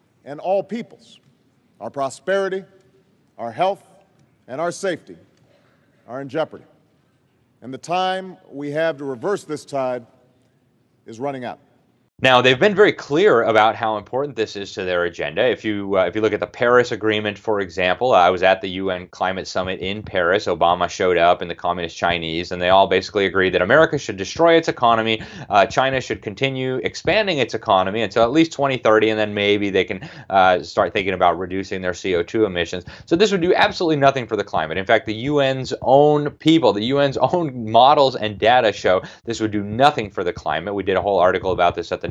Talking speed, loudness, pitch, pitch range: 200 wpm, -19 LUFS, 125 Hz, 105-150 Hz